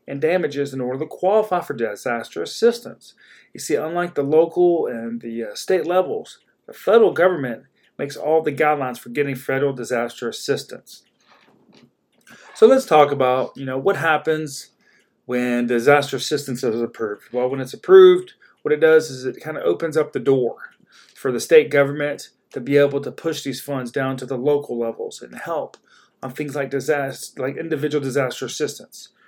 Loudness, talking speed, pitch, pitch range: -20 LUFS, 175 wpm, 145 Hz, 130-175 Hz